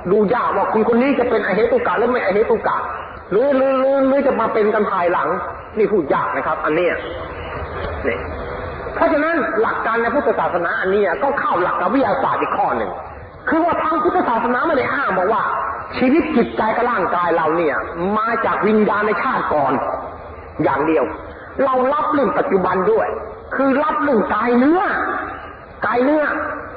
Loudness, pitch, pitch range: -18 LUFS, 265 Hz, 220-315 Hz